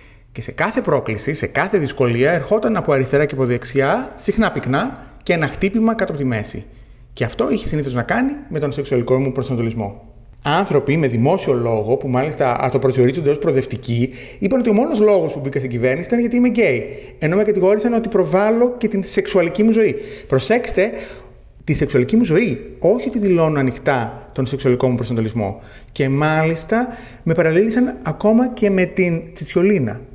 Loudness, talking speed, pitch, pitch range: -18 LUFS, 175 wpm, 145 Hz, 125-205 Hz